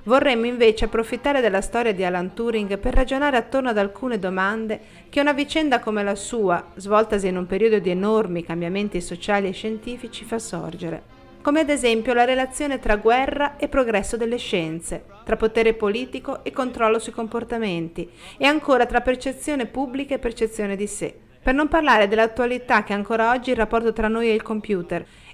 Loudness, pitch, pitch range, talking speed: -22 LUFS, 225 Hz, 205-255 Hz, 175 wpm